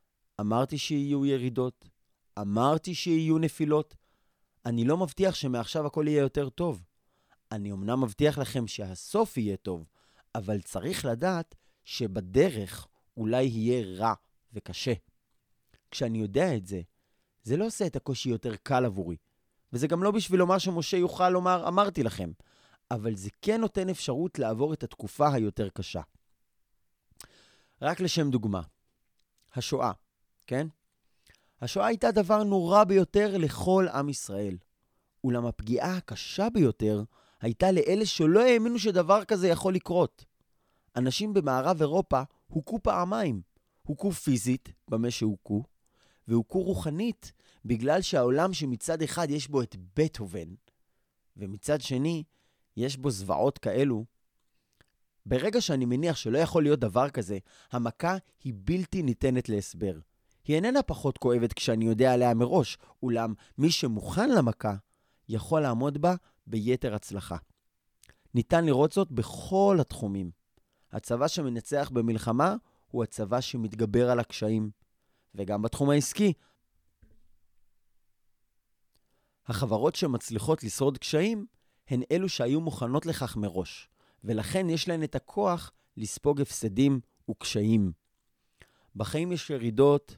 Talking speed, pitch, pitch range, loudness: 120 wpm, 130 Hz, 110-165 Hz, -29 LUFS